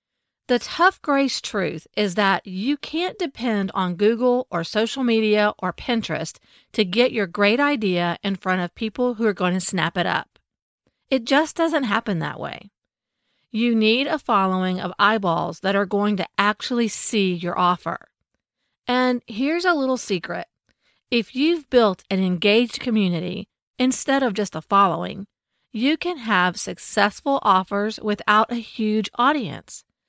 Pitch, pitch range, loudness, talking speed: 215 Hz, 195-250 Hz, -21 LUFS, 155 wpm